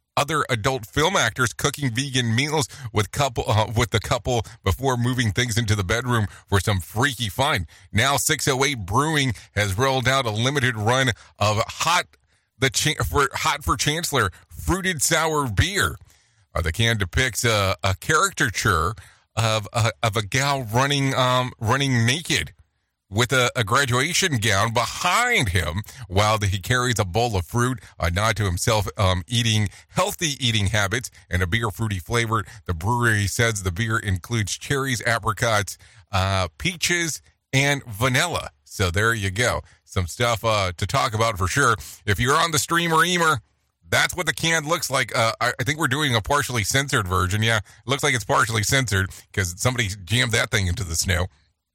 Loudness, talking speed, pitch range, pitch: -22 LUFS, 175 wpm, 100-130 Hz, 115 Hz